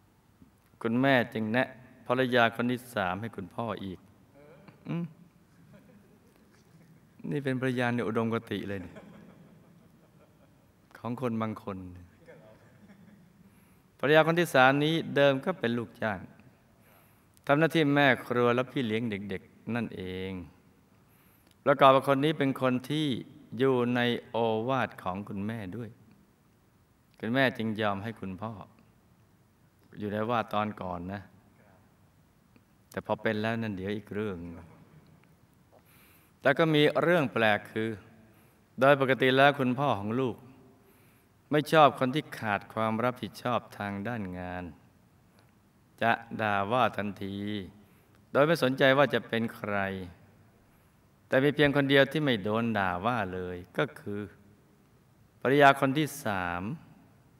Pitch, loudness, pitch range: 115 Hz, -28 LUFS, 100-135 Hz